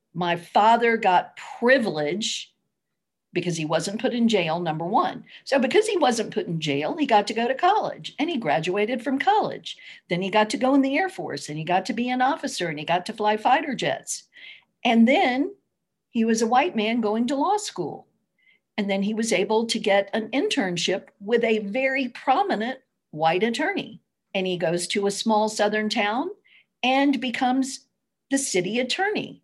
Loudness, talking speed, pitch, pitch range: -23 LUFS, 190 wpm, 225 Hz, 195-265 Hz